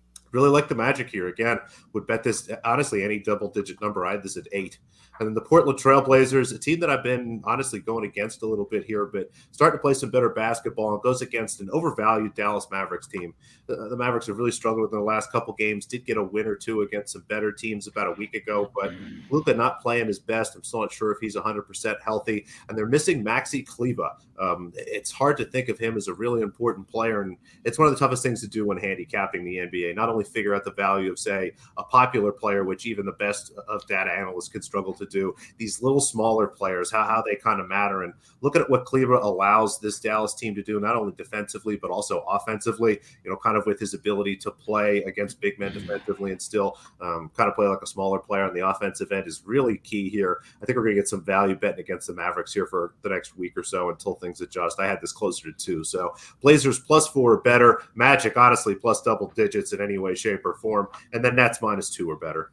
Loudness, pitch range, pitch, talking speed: -24 LUFS, 100-125 Hz, 110 Hz, 240 wpm